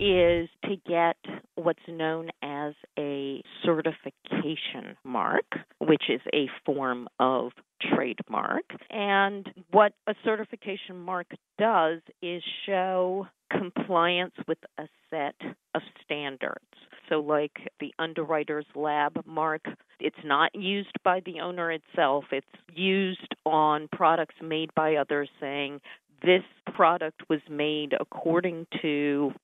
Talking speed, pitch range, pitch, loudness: 115 wpm, 150-185 Hz, 165 Hz, -28 LUFS